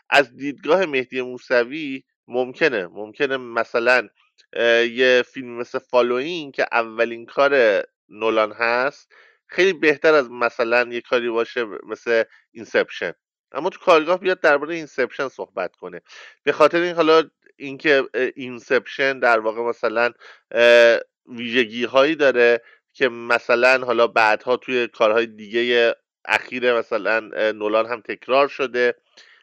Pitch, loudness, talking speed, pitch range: 120 Hz, -20 LUFS, 120 wpm, 115-140 Hz